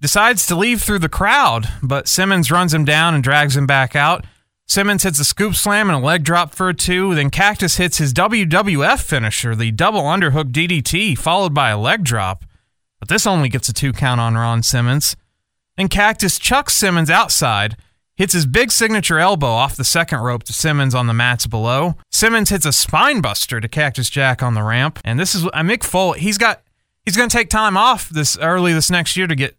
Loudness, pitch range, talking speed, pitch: -15 LUFS, 130-190 Hz, 215 wpm, 155 Hz